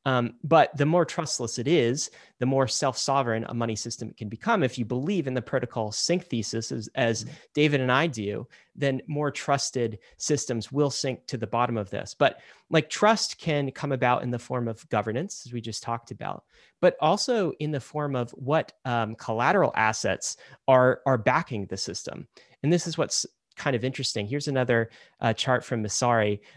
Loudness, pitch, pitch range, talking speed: -26 LUFS, 130 Hz, 115-145 Hz, 190 wpm